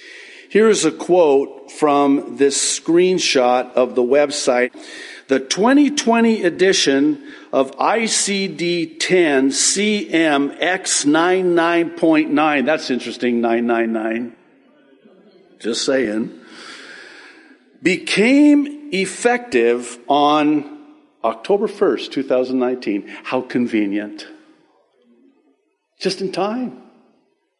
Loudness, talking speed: -17 LUFS, 70 wpm